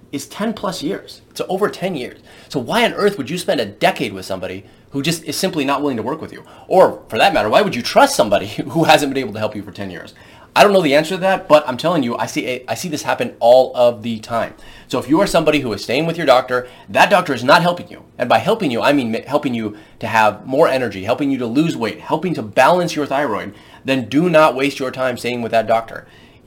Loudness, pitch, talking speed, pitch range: -16 LUFS, 135 Hz, 270 wpm, 115-155 Hz